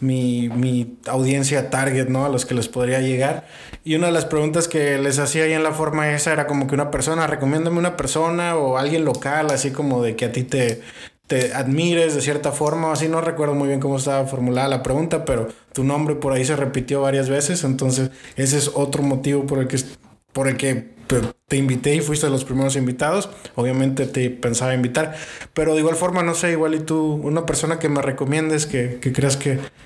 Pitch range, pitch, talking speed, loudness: 130-155 Hz, 140 Hz, 215 wpm, -20 LUFS